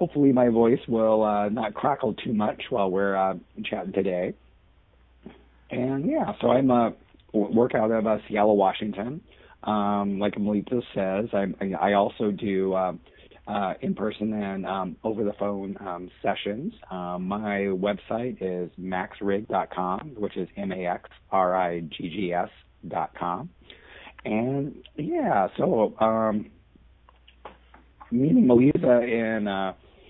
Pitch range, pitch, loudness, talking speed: 95-110 Hz, 100 Hz, -26 LUFS, 120 wpm